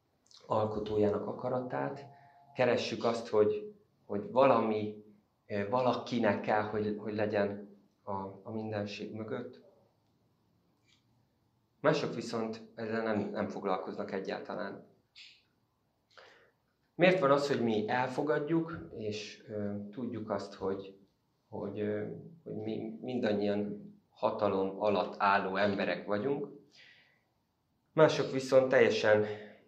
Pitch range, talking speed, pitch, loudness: 105-120 Hz, 95 wpm, 105 Hz, -33 LUFS